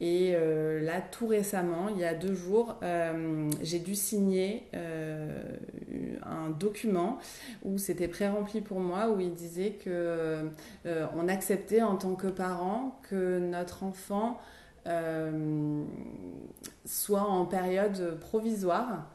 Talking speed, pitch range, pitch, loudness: 125 wpm, 170-205 Hz, 185 Hz, -32 LUFS